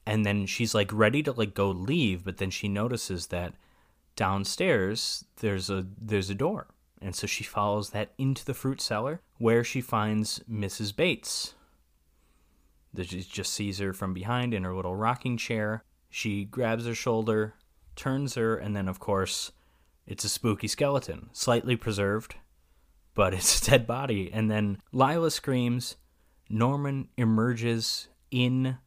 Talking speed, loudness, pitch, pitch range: 150 wpm, -29 LUFS, 105 Hz, 95-120 Hz